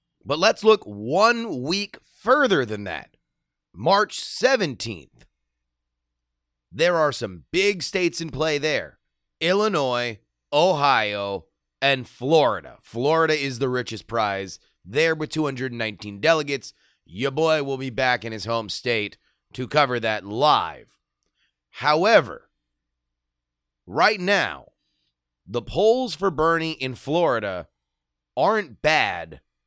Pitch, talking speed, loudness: 125 Hz, 110 wpm, -22 LUFS